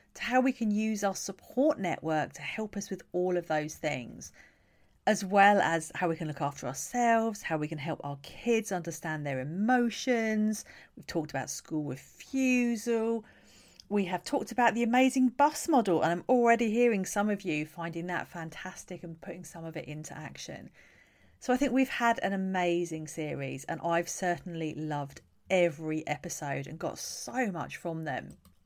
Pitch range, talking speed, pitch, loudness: 155-225 Hz, 175 wpm, 180 Hz, -30 LUFS